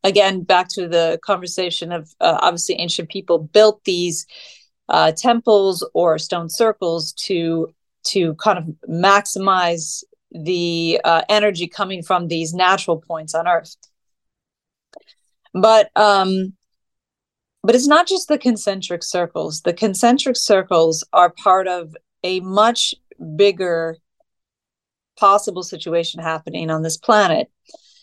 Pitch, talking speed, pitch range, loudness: 185 Hz, 120 wpm, 170-210 Hz, -17 LUFS